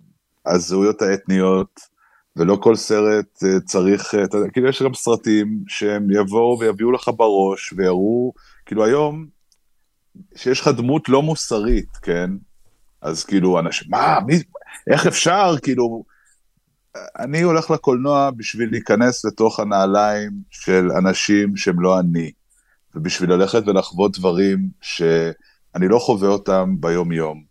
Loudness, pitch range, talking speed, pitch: -18 LUFS, 95-120 Hz, 120 wpm, 105 Hz